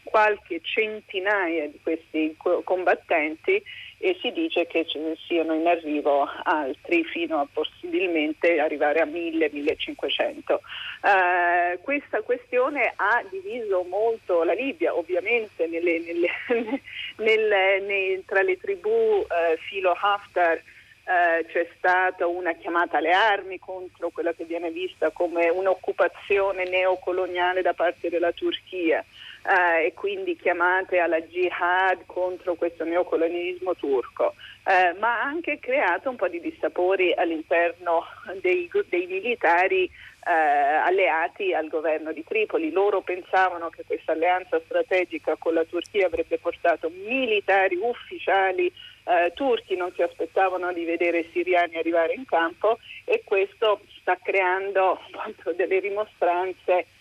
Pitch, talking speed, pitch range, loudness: 185 Hz, 125 wpm, 170-245 Hz, -24 LUFS